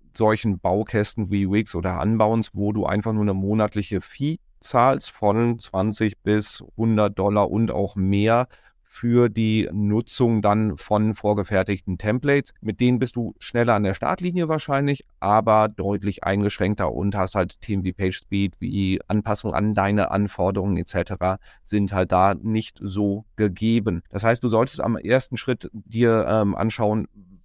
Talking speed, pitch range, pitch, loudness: 155 wpm, 100-115 Hz, 105 Hz, -22 LUFS